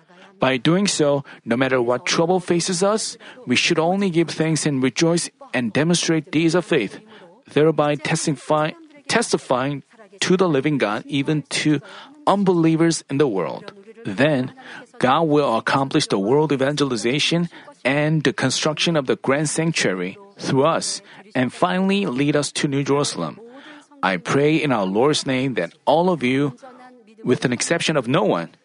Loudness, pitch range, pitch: -20 LUFS, 140-180 Hz, 155 Hz